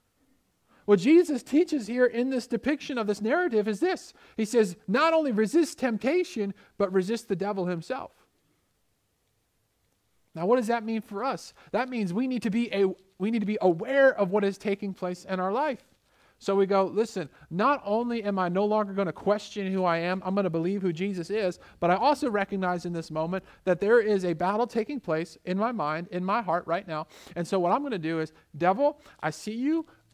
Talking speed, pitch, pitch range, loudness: 210 wpm, 200 Hz, 180-240 Hz, -27 LUFS